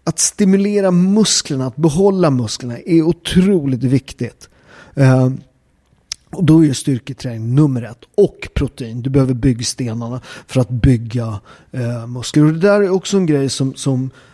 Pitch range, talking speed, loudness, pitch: 125-170 Hz, 145 wpm, -15 LUFS, 135 Hz